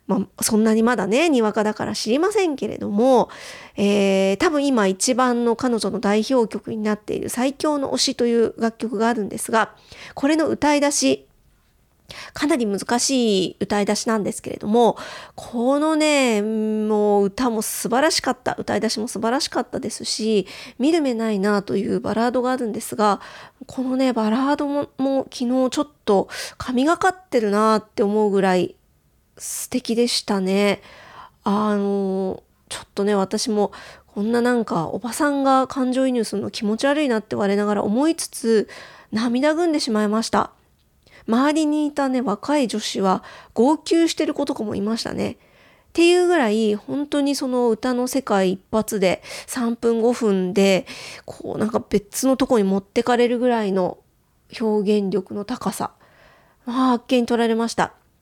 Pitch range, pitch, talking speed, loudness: 210-265 Hz, 230 Hz, 320 characters per minute, -21 LUFS